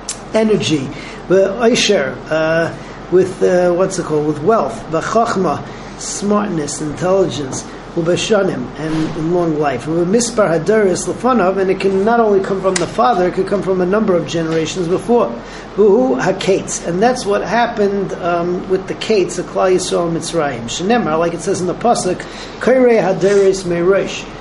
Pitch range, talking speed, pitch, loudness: 165-205 Hz, 155 wpm, 185 Hz, -15 LUFS